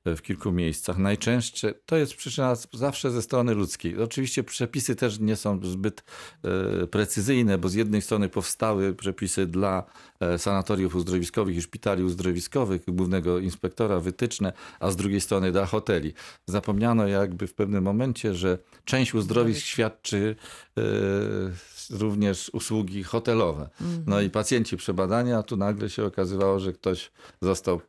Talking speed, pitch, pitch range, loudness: 140 wpm, 100 Hz, 95-115 Hz, -27 LUFS